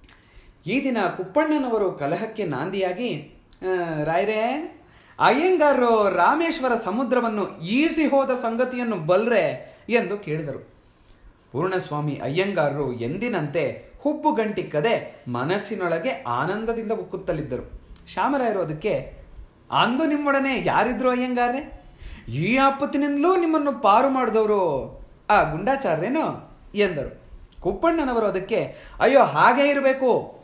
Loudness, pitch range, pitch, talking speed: -22 LUFS, 180-270 Hz, 225 Hz, 80 wpm